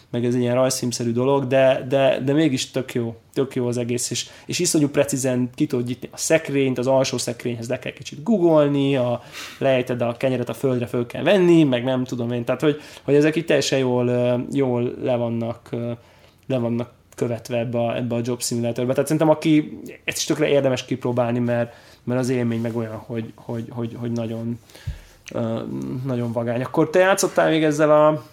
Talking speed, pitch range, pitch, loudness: 185 wpm, 120-140 Hz, 125 Hz, -21 LUFS